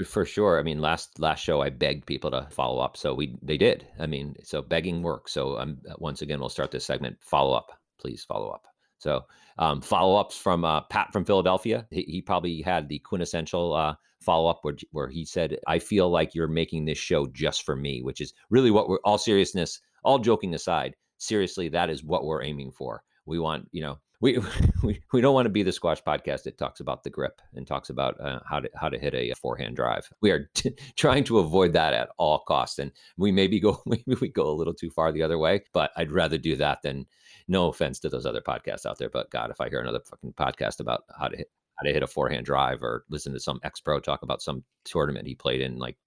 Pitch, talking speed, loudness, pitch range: 85 Hz, 240 wpm, -27 LUFS, 75-100 Hz